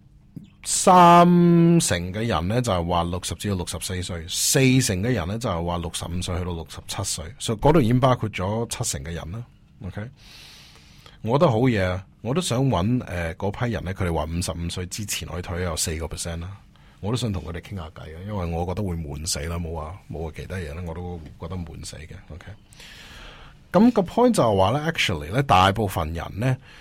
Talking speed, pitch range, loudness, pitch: 330 characters per minute, 85-120 Hz, -22 LUFS, 95 Hz